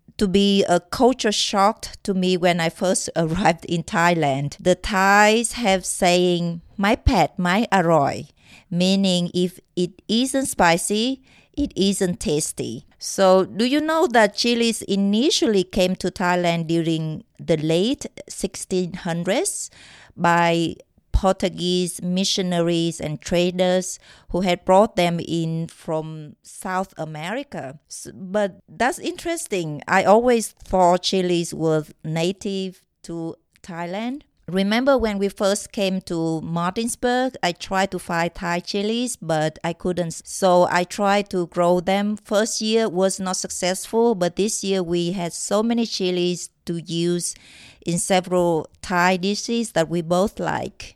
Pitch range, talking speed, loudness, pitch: 170-205 Hz, 130 wpm, -21 LUFS, 185 Hz